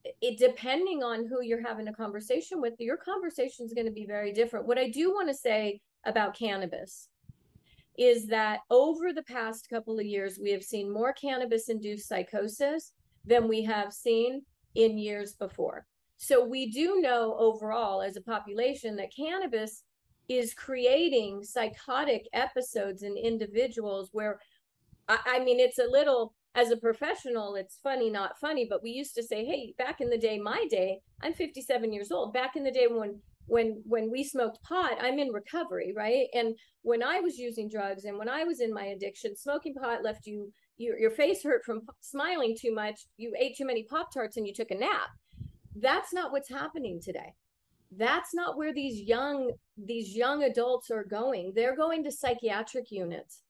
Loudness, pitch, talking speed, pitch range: -31 LUFS, 235 Hz, 185 wpm, 215-270 Hz